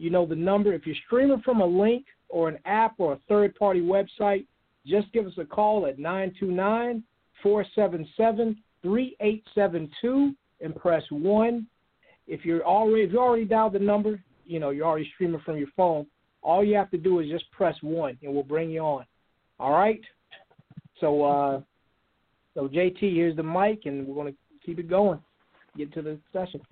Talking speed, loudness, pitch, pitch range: 175 wpm, -26 LUFS, 185 Hz, 160-210 Hz